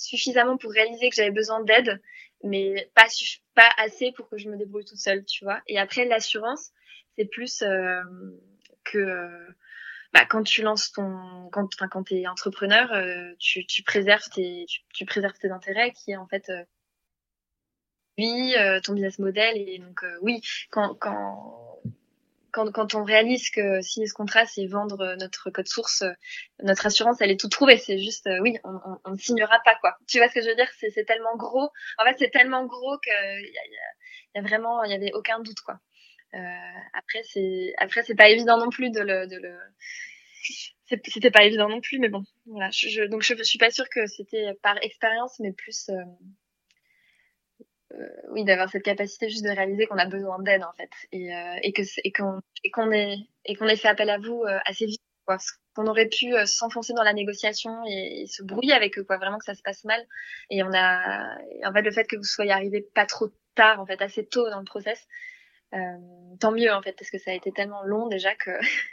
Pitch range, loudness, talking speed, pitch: 195-230 Hz, -23 LUFS, 210 wpm, 210 Hz